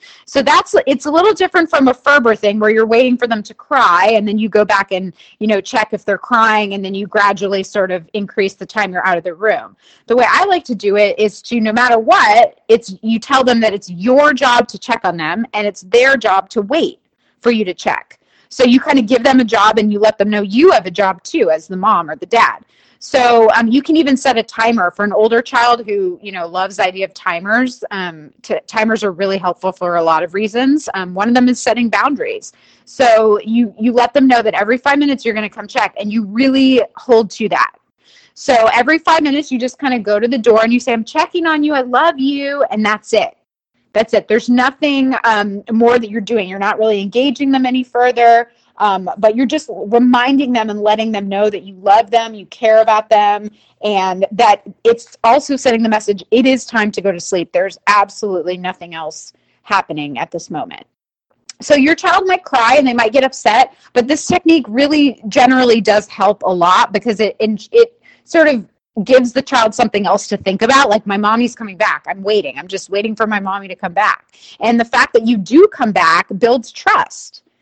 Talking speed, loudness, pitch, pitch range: 230 wpm, -13 LUFS, 225 Hz, 205-260 Hz